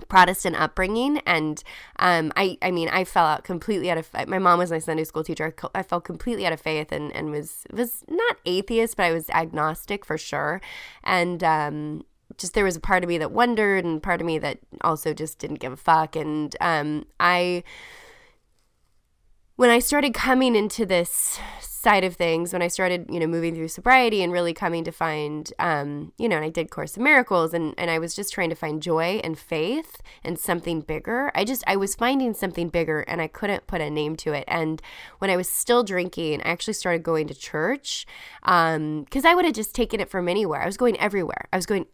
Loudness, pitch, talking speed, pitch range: -23 LUFS, 175 Hz, 220 wpm, 160-205 Hz